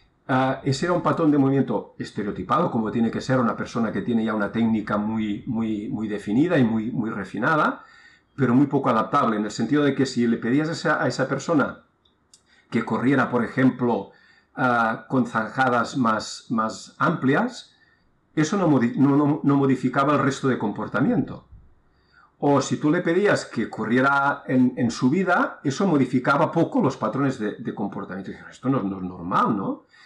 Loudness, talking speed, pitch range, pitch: -23 LUFS, 185 wpm, 115-140 Hz, 130 Hz